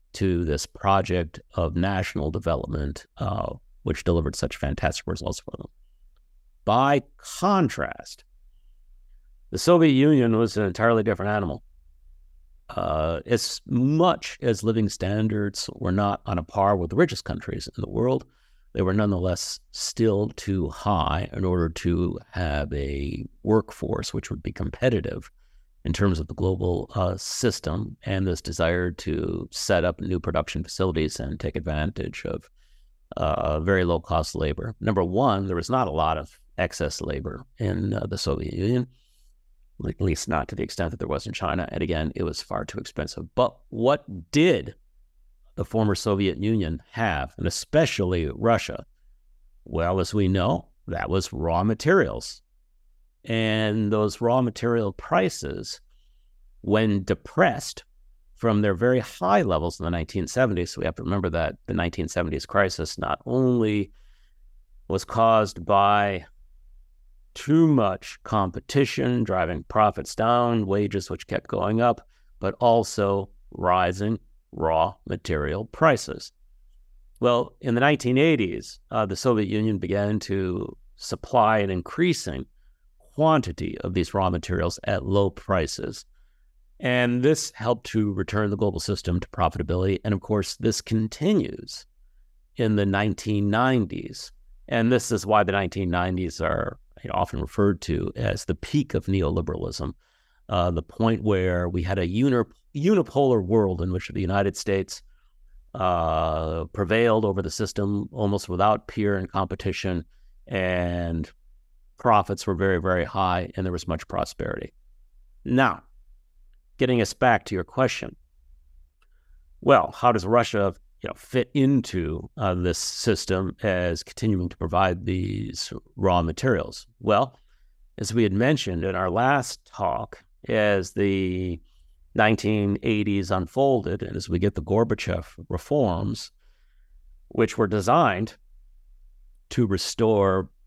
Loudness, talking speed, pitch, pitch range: -25 LUFS, 135 wpm, 95 Hz, 85-110 Hz